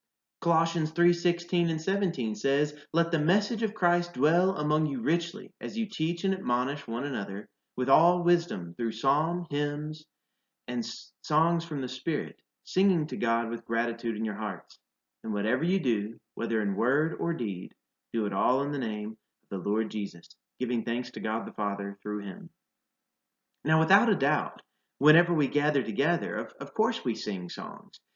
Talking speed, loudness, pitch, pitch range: 175 wpm, -29 LUFS, 150 Hz, 115-175 Hz